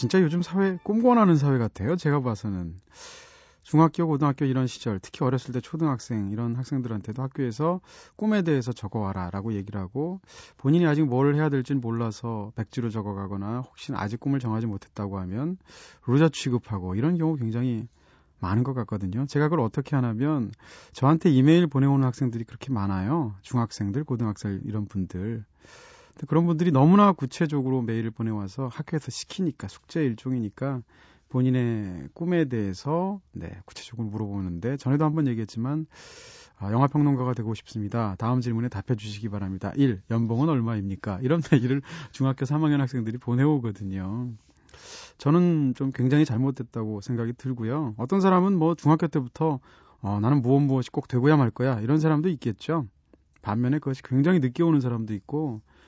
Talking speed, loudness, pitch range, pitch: 380 characters per minute, -26 LUFS, 110-150 Hz, 125 Hz